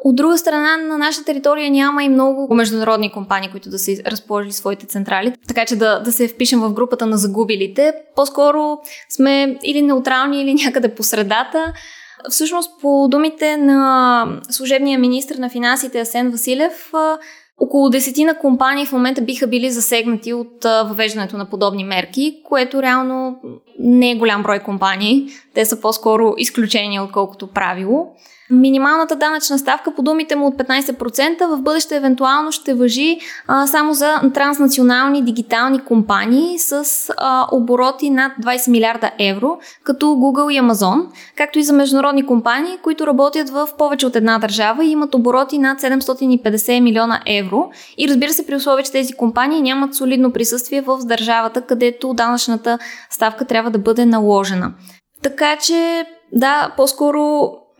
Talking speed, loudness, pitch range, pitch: 150 wpm, -15 LUFS, 230-290 Hz, 260 Hz